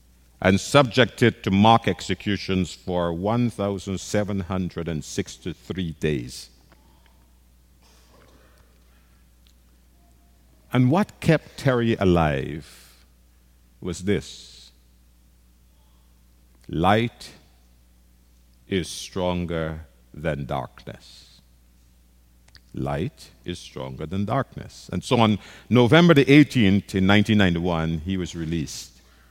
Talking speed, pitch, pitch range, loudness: 75 wpm, 75 Hz, 60-95 Hz, -22 LUFS